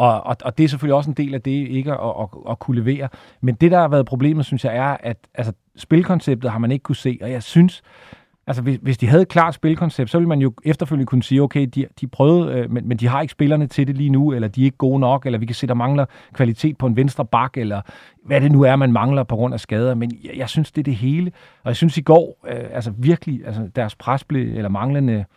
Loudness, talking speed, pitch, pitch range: -18 LUFS, 270 wpm, 135 Hz, 125-145 Hz